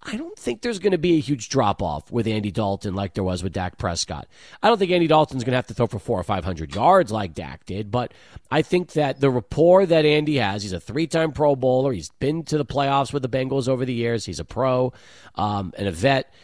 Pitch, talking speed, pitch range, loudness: 130 Hz, 260 wpm, 100-150 Hz, -22 LUFS